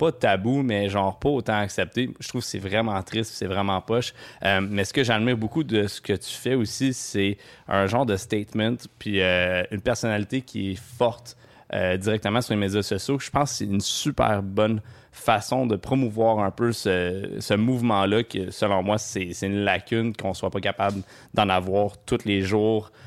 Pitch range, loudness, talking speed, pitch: 100-120 Hz, -25 LUFS, 200 wpm, 105 Hz